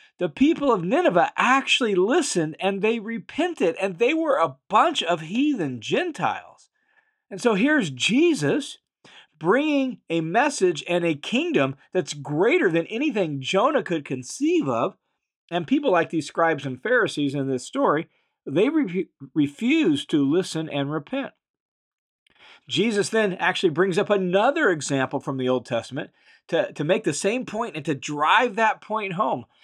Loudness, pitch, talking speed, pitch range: -23 LUFS, 190 Hz, 150 wpm, 155-260 Hz